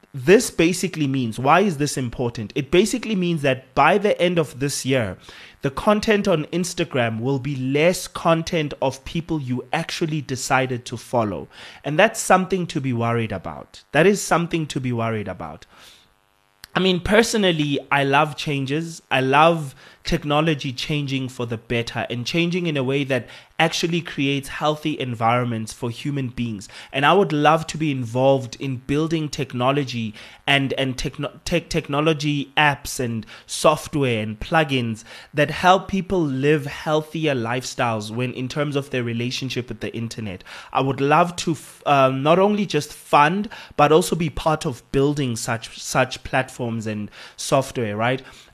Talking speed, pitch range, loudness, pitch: 160 wpm, 120-160 Hz, -21 LUFS, 140 Hz